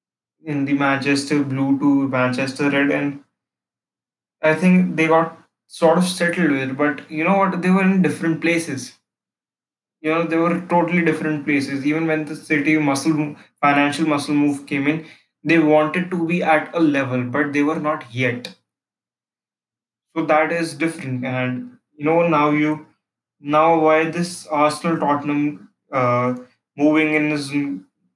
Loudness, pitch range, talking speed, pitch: -19 LUFS, 140-165 Hz, 155 wpm, 150 Hz